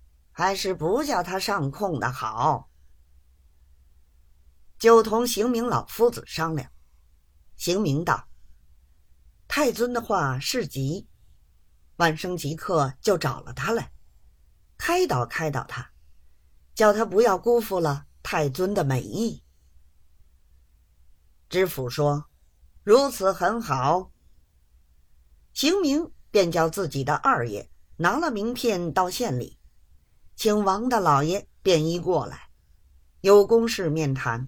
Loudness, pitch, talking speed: -24 LUFS, 135 Hz, 155 characters per minute